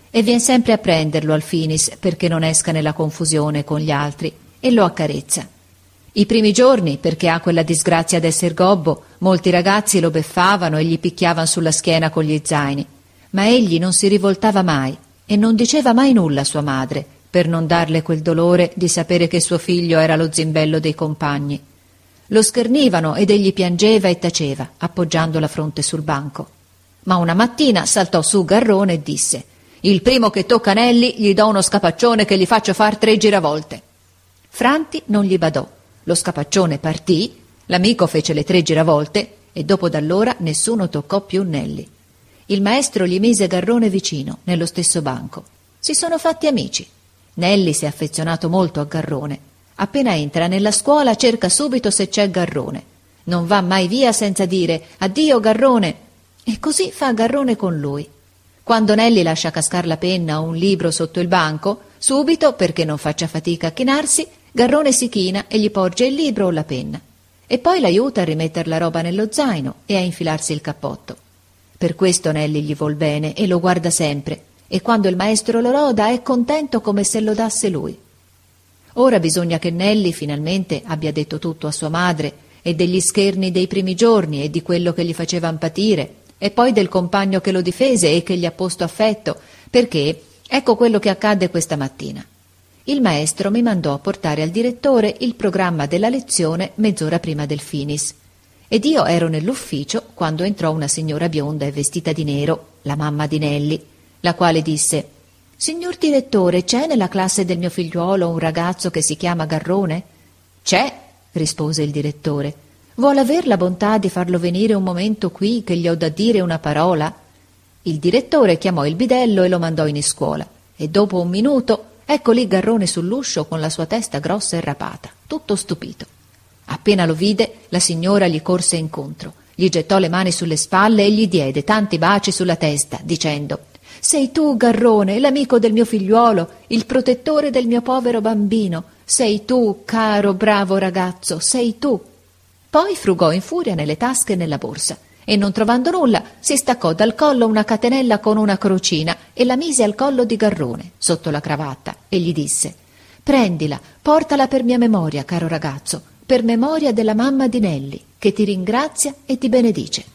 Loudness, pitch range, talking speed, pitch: -17 LUFS, 160-220 Hz, 175 wpm, 180 Hz